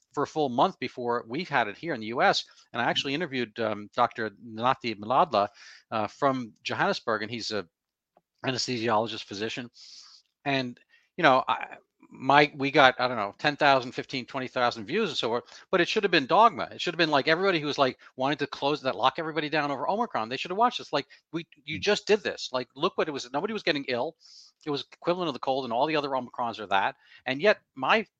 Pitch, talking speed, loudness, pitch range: 135 Hz, 225 wpm, -27 LUFS, 120-155 Hz